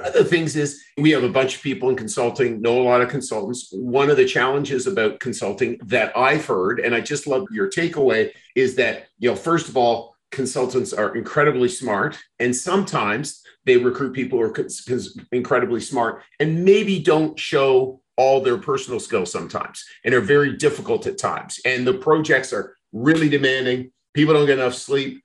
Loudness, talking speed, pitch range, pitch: -20 LUFS, 190 wpm, 125-195 Hz, 145 Hz